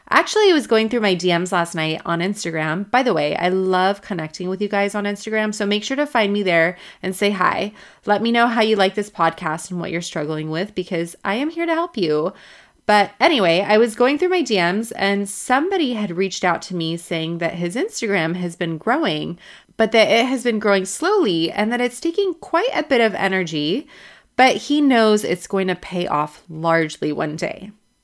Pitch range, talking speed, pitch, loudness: 175-235 Hz, 215 wpm, 200 Hz, -19 LUFS